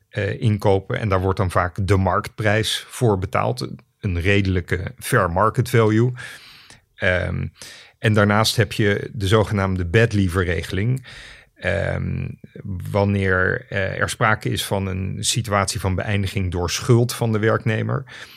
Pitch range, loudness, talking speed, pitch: 95-115 Hz, -20 LUFS, 135 wpm, 105 Hz